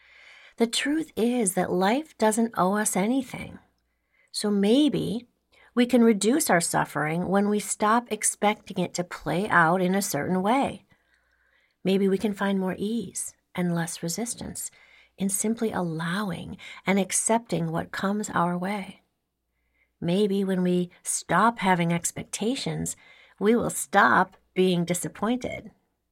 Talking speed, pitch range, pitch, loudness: 130 wpm, 180-225 Hz, 200 Hz, -25 LUFS